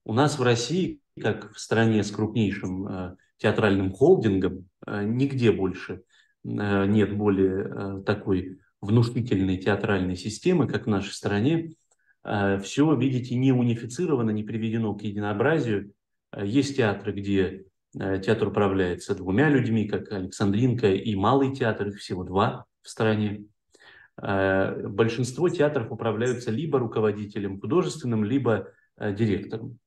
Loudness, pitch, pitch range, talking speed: -25 LUFS, 105 Hz, 100-120 Hz, 115 wpm